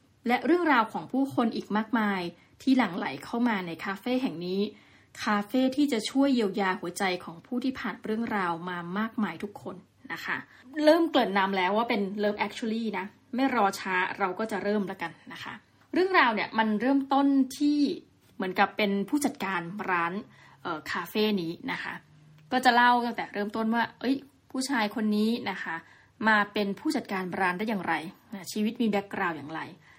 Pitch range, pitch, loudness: 195-250 Hz, 215 Hz, -28 LUFS